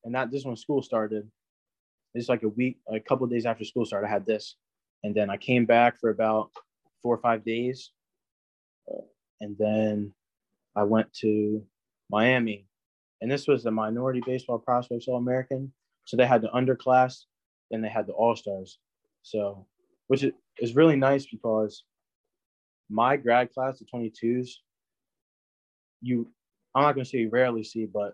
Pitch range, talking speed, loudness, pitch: 110-130 Hz, 165 wpm, -27 LUFS, 115 Hz